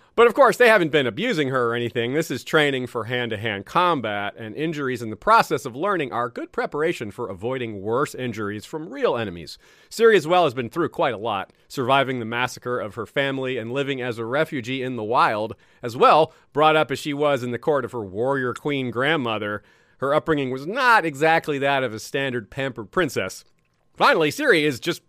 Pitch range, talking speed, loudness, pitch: 120-155 Hz, 205 wpm, -22 LUFS, 130 Hz